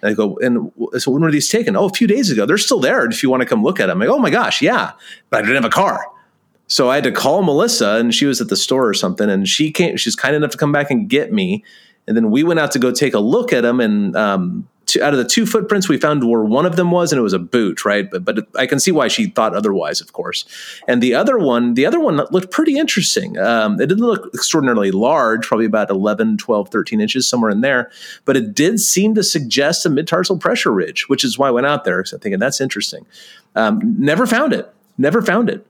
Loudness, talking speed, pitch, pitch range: -15 LUFS, 265 wpm, 185 Hz, 135-220 Hz